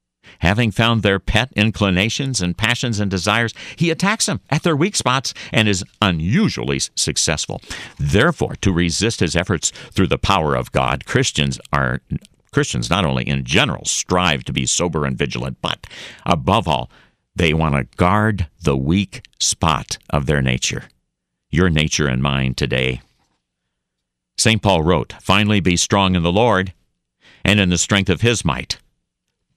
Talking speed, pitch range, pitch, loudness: 155 wpm, 70-110 Hz, 90 Hz, -18 LUFS